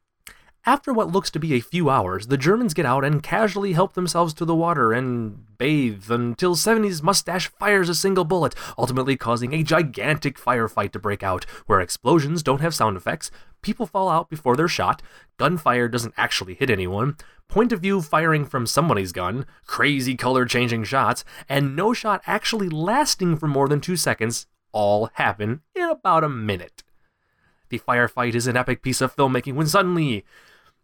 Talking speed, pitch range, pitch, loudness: 175 wpm, 125-180 Hz, 145 Hz, -22 LUFS